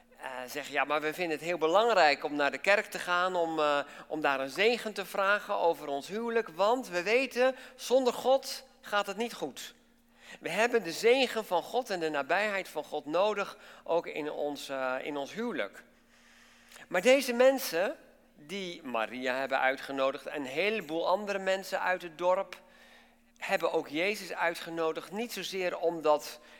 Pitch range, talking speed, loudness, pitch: 150-235 Hz, 170 wpm, -30 LUFS, 185 Hz